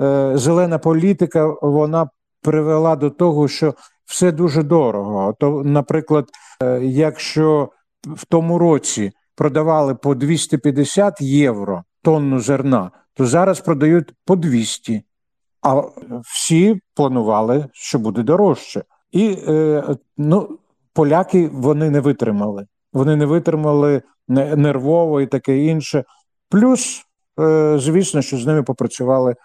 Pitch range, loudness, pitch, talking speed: 135-160 Hz, -17 LUFS, 150 Hz, 105 wpm